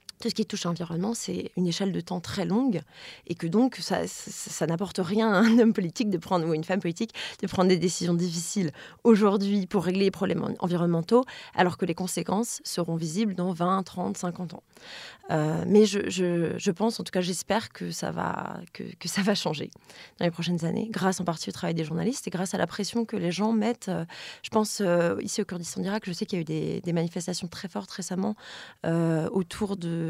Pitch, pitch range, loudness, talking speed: 185 Hz, 175-210 Hz, -27 LUFS, 225 wpm